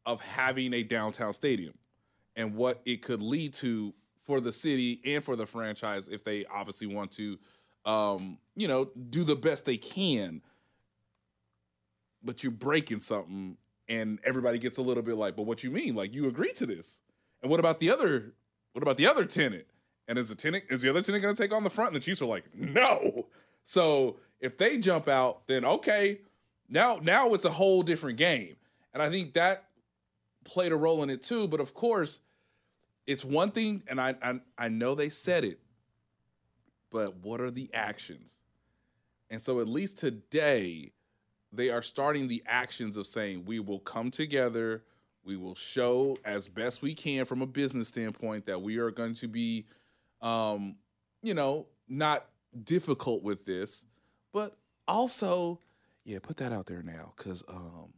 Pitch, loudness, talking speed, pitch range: 125 Hz, -31 LUFS, 180 wpm, 110-145 Hz